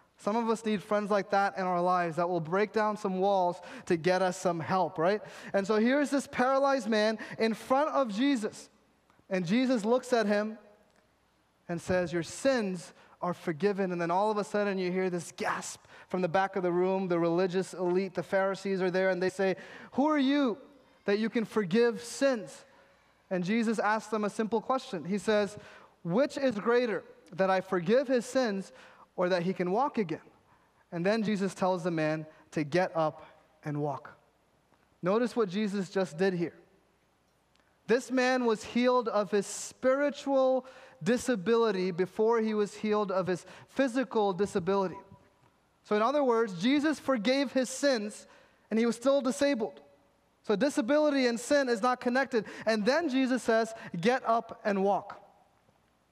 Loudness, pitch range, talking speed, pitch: -30 LUFS, 185-250 Hz, 170 wpm, 210 Hz